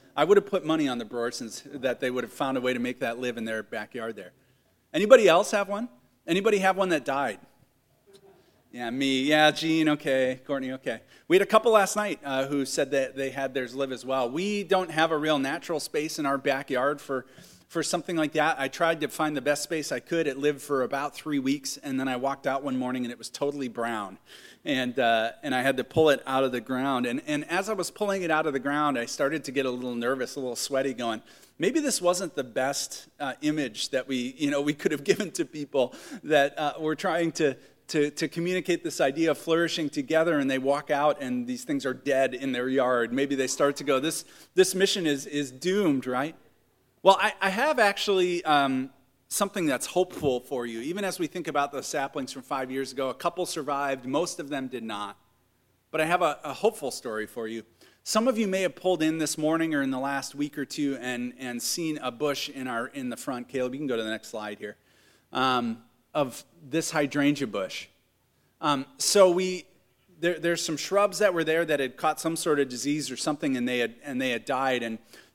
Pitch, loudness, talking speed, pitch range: 145 Hz, -27 LUFS, 230 wpm, 130-170 Hz